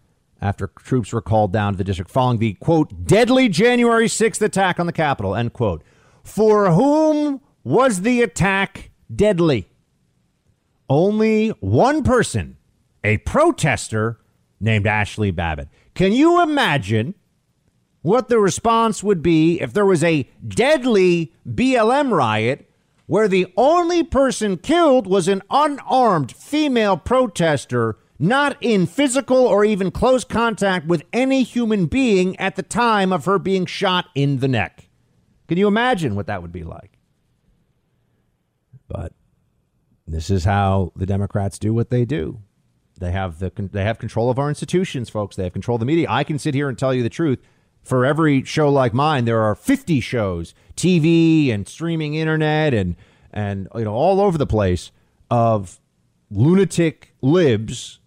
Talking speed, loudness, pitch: 150 wpm, -18 LUFS, 155 Hz